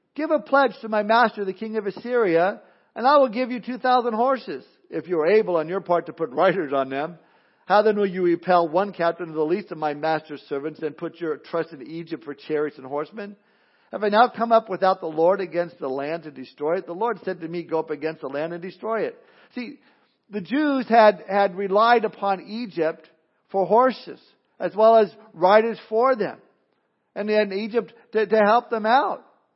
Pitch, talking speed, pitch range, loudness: 195 Hz, 215 wpm, 165-225 Hz, -22 LUFS